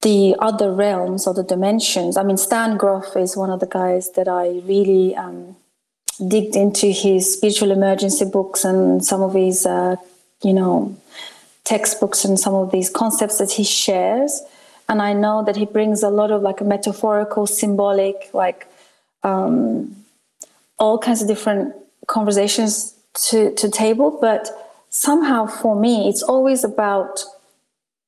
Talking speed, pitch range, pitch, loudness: 150 wpm, 195-220 Hz, 205 Hz, -18 LUFS